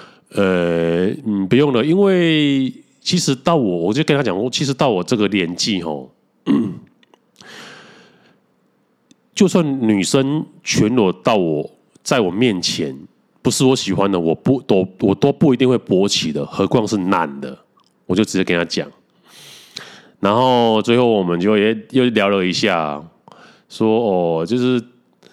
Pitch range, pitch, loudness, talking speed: 95-140 Hz, 115 Hz, -17 LUFS, 205 characters per minute